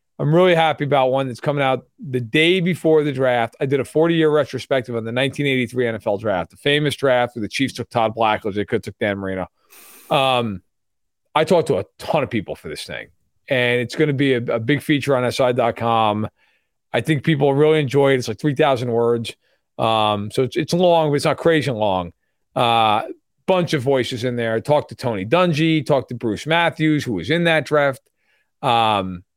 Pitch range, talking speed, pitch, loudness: 115-150 Hz, 210 wpm, 130 Hz, -19 LUFS